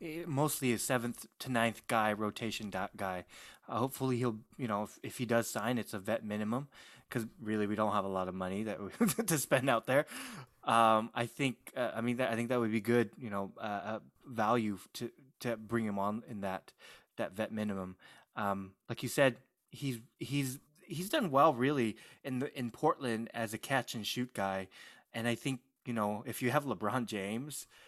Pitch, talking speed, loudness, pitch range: 115 Hz, 205 wpm, -35 LUFS, 105-130 Hz